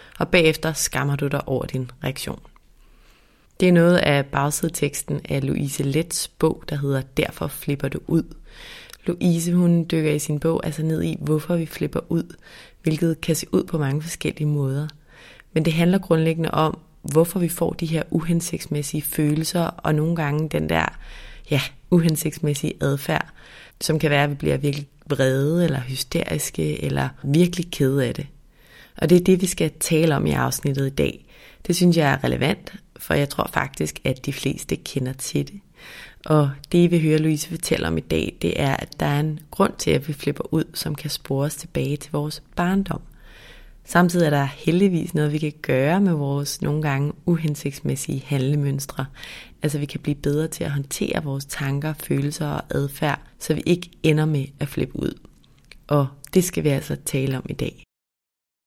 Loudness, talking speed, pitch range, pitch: -22 LUFS, 180 wpm, 140-165 Hz, 150 Hz